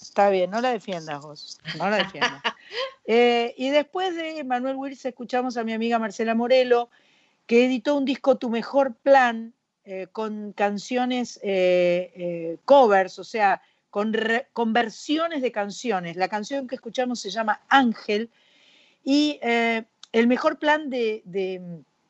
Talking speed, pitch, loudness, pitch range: 150 wpm, 235 Hz, -23 LUFS, 205-270 Hz